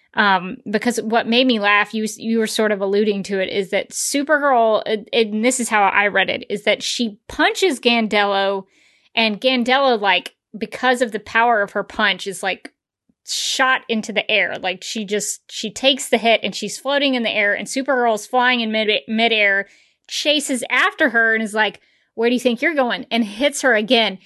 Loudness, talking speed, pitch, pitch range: -18 LUFS, 205 wpm, 225 Hz, 205-255 Hz